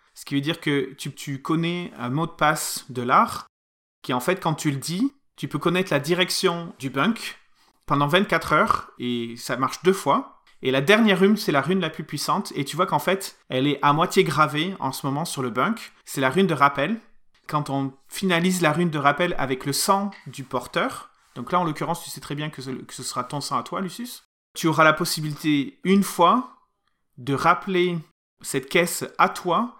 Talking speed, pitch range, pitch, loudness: 220 wpm, 140-180 Hz, 155 Hz, -23 LUFS